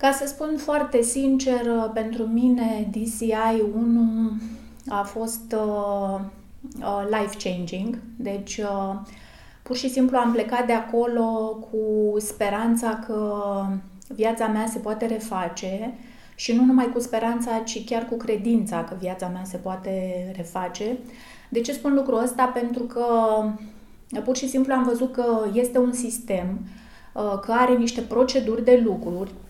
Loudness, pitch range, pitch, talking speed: -24 LUFS, 210-240 Hz, 225 Hz, 140 wpm